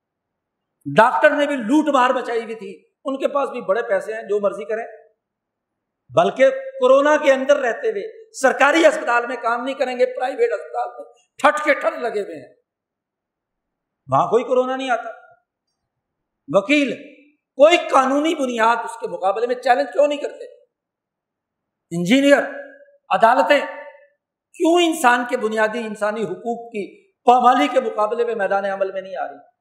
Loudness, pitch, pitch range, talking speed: -18 LUFS, 265 Hz, 230-295 Hz, 155 wpm